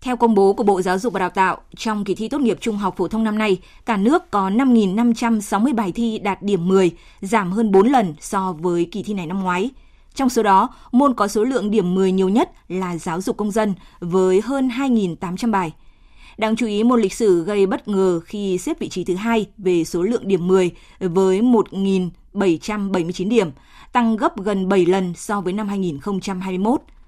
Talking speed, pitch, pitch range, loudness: 205 wpm, 200 Hz, 185-230 Hz, -19 LUFS